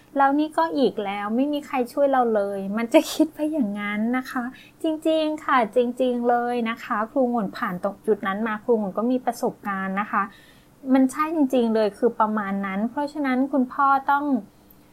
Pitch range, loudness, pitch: 215-280 Hz, -23 LUFS, 245 Hz